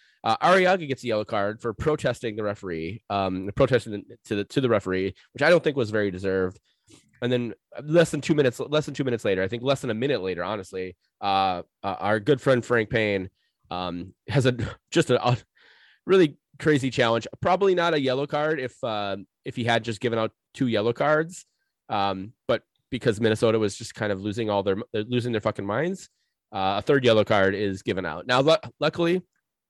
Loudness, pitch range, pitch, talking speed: -25 LUFS, 100-140 Hz, 115 Hz, 200 wpm